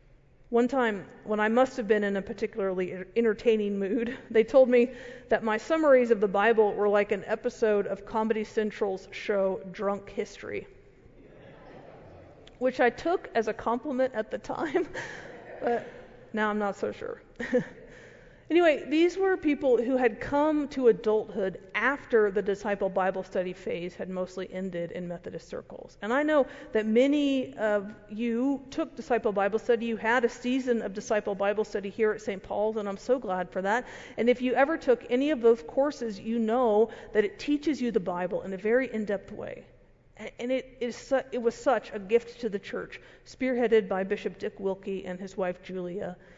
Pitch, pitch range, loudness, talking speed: 225 Hz, 200-250 Hz, -28 LUFS, 180 wpm